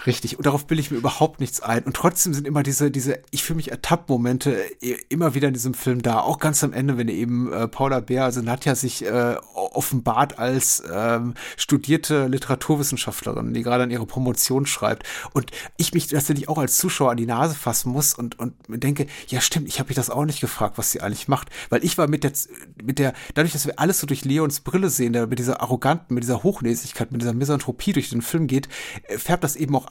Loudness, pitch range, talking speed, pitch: -22 LUFS, 125-150 Hz, 225 wpm, 135 Hz